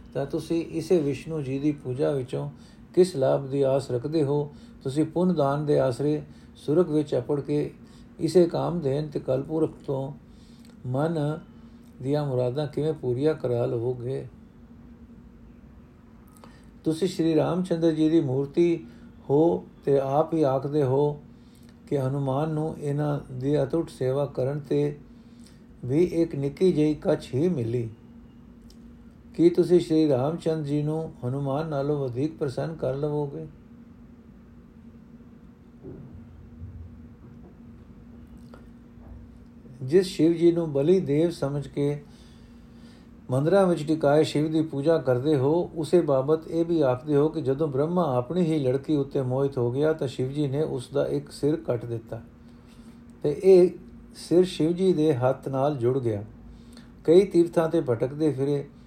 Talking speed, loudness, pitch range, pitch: 135 wpm, -25 LUFS, 135-160 Hz, 150 Hz